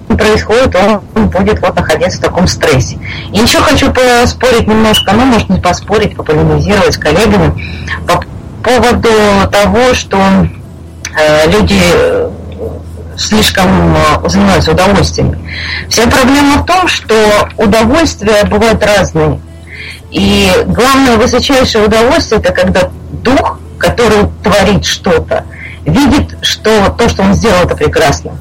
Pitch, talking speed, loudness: 205 Hz, 115 wpm, -8 LUFS